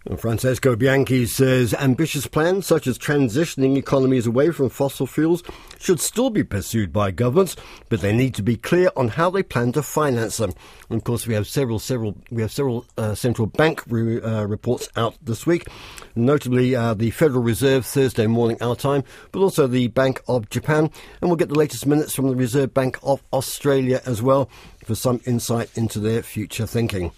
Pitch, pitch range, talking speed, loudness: 125 Hz, 115-140 Hz, 195 wpm, -21 LUFS